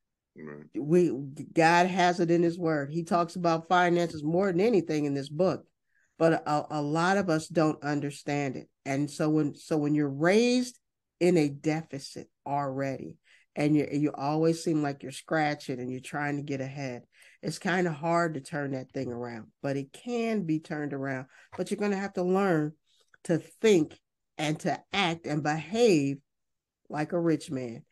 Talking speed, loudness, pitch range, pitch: 180 wpm, -28 LUFS, 140-170 Hz, 155 Hz